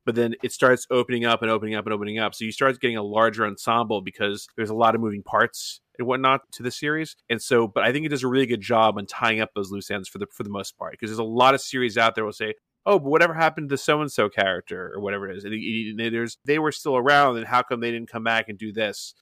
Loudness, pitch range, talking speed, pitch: -23 LUFS, 110-130 Hz, 300 wpm, 115 Hz